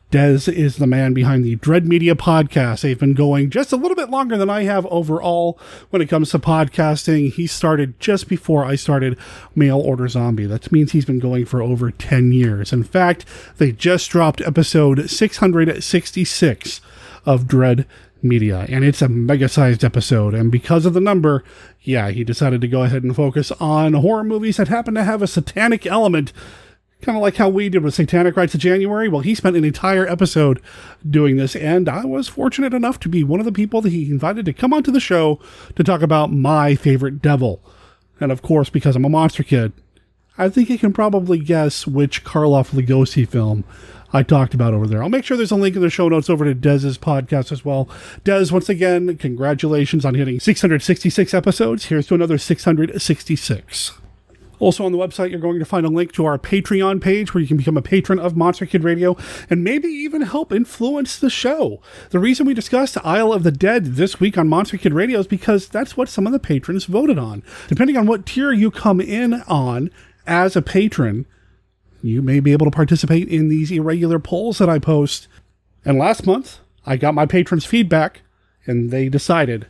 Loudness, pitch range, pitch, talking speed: -17 LUFS, 135-190 Hz, 160 Hz, 200 wpm